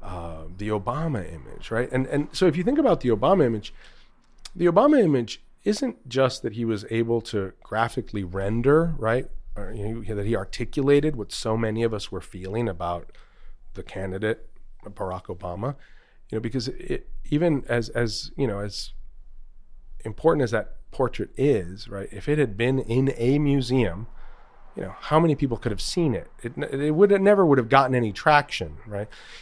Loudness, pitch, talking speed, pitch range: -24 LUFS, 120 Hz, 180 wpm, 105-145 Hz